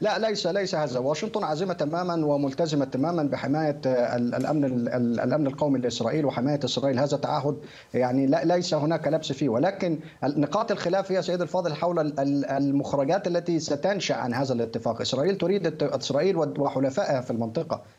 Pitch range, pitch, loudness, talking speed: 135-170 Hz, 145 Hz, -26 LUFS, 145 wpm